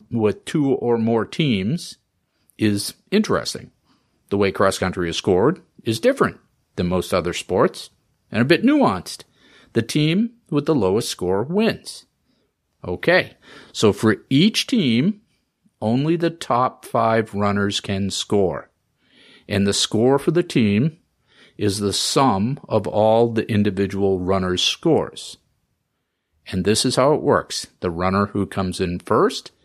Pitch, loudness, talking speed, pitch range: 110 Hz, -20 LUFS, 140 wpm, 100-160 Hz